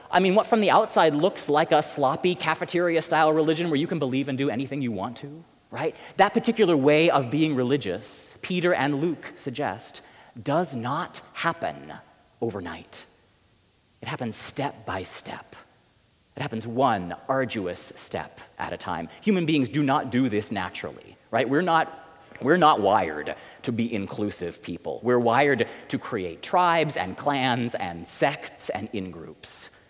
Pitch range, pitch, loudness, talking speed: 115-160 Hz, 140 Hz, -25 LUFS, 160 wpm